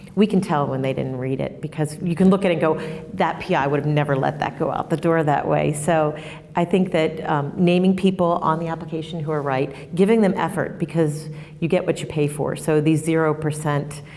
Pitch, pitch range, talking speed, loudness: 160 Hz, 150-175 Hz, 235 wpm, -21 LUFS